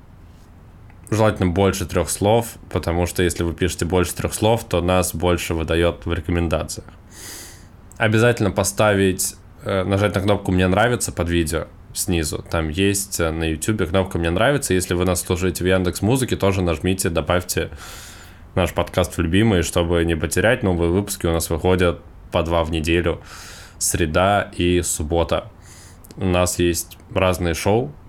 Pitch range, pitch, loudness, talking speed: 85-100 Hz, 90 Hz, -20 LUFS, 145 wpm